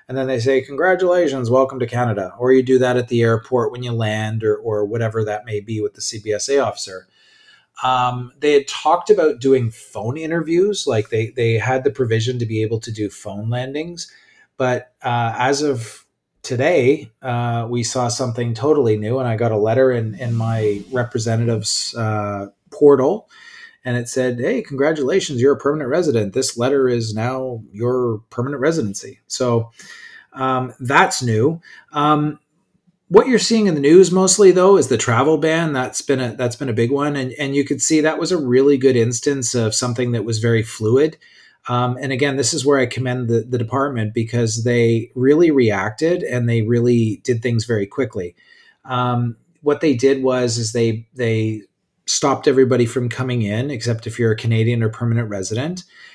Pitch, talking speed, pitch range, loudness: 125 Hz, 185 wpm, 115-140 Hz, -18 LUFS